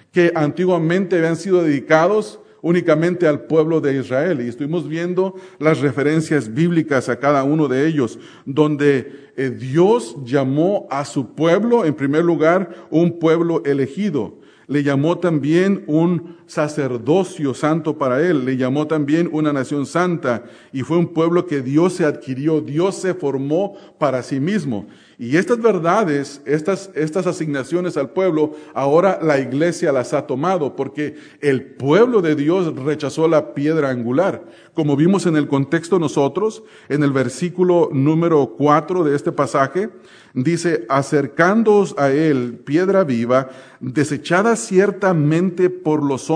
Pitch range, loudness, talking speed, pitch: 140-175 Hz, -18 LUFS, 140 wpm, 155 Hz